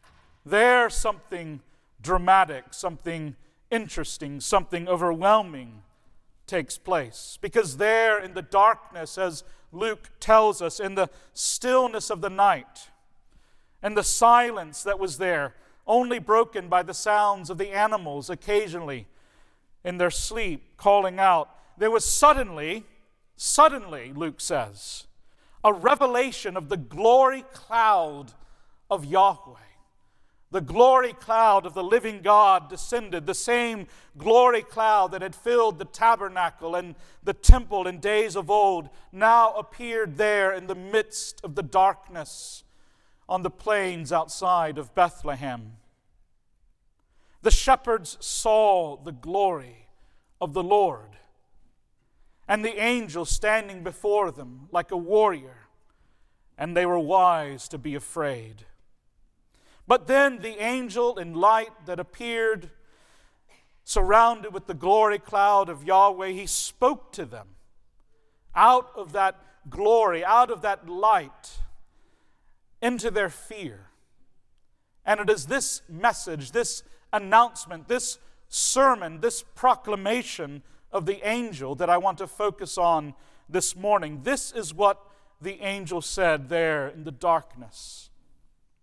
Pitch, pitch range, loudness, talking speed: 195 Hz, 165-220 Hz, -23 LUFS, 125 wpm